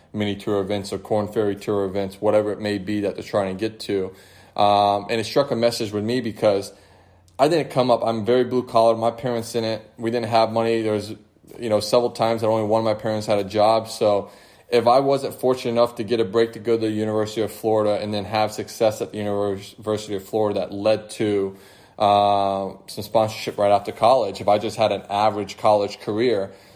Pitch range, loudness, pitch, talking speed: 100-115 Hz, -22 LUFS, 105 Hz, 220 wpm